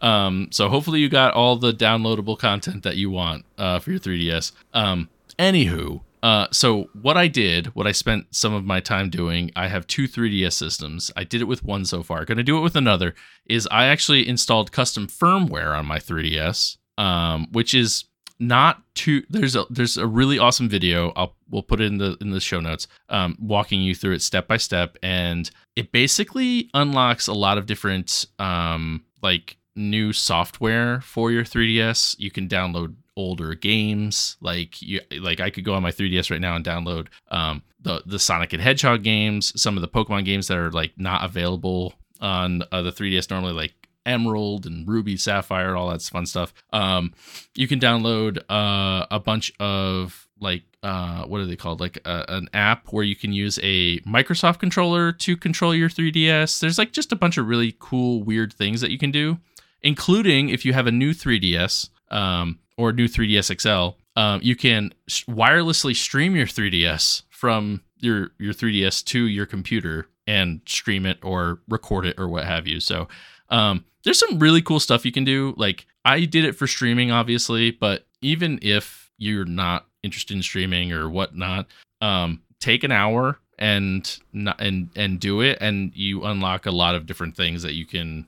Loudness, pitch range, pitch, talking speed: -21 LUFS, 90-120 Hz, 100 Hz, 190 wpm